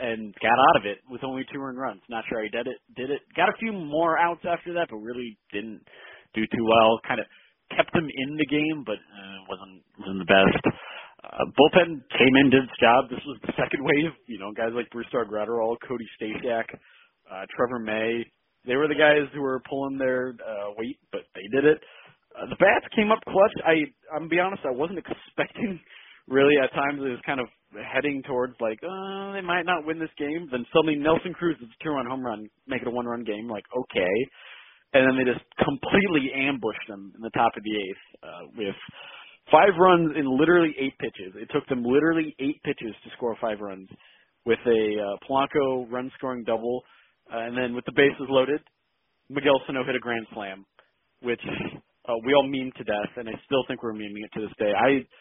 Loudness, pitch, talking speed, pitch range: -25 LUFS, 130 Hz, 215 wpm, 115-150 Hz